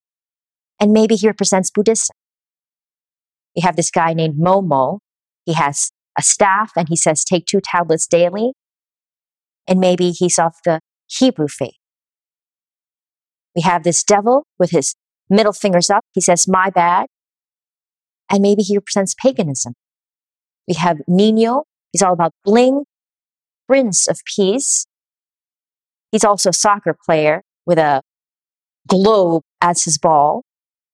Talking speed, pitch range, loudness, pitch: 130 wpm, 170-210 Hz, -15 LUFS, 185 Hz